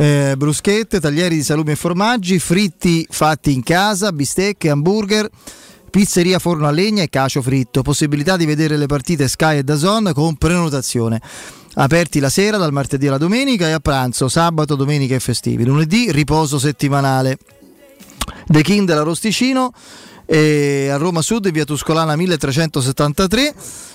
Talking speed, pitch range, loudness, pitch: 145 wpm, 145-185 Hz, -15 LUFS, 155 Hz